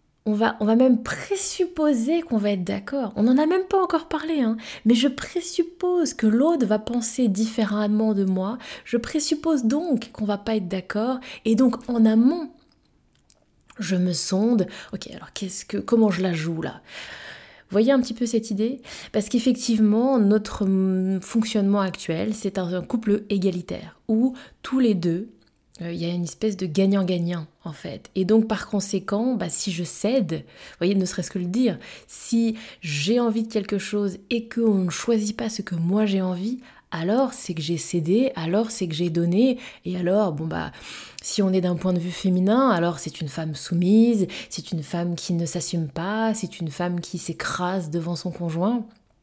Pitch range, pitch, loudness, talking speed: 180-240 Hz, 210 Hz, -23 LUFS, 190 wpm